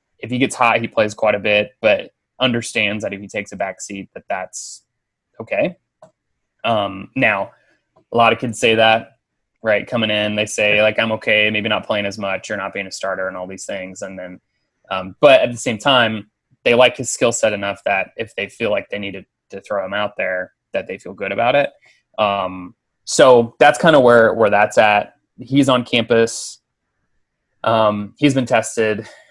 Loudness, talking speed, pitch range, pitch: -17 LUFS, 205 wpm, 100-115 Hz, 105 Hz